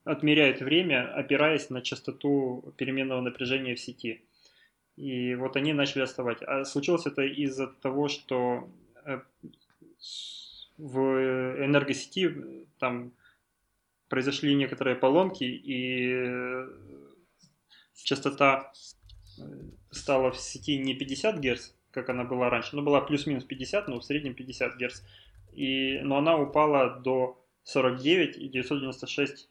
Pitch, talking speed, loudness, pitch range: 130 Hz, 115 wpm, -28 LUFS, 125-140 Hz